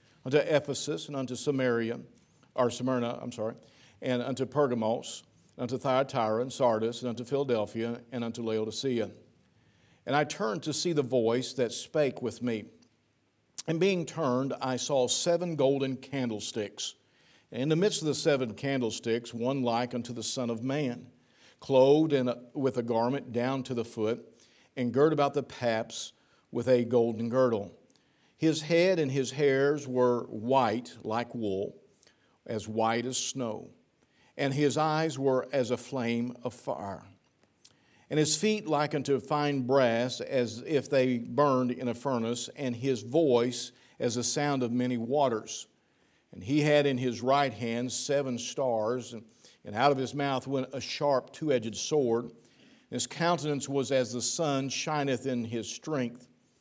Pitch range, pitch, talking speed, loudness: 120-140 Hz, 125 Hz, 160 wpm, -30 LUFS